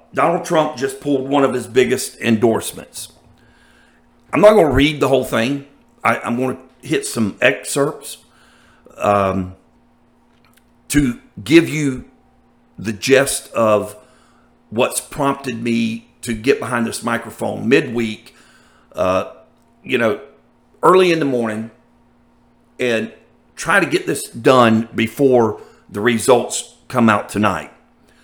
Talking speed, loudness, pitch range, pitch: 125 wpm, -17 LUFS, 110-140 Hz, 125 Hz